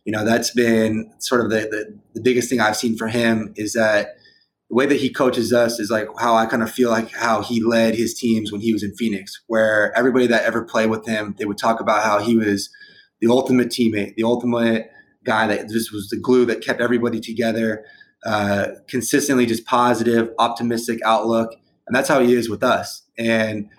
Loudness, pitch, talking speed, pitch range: -19 LUFS, 115 Hz, 210 wpm, 110-120 Hz